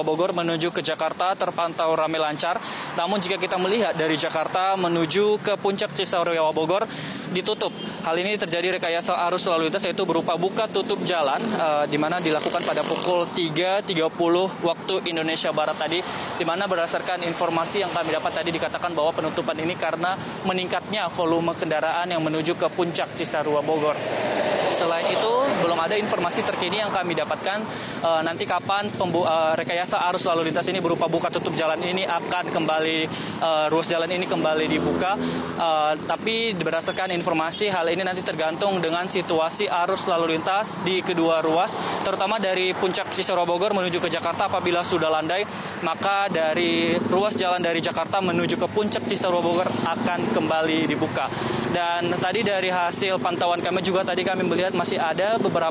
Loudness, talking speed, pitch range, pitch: -23 LUFS, 160 wpm, 165-190 Hz, 175 Hz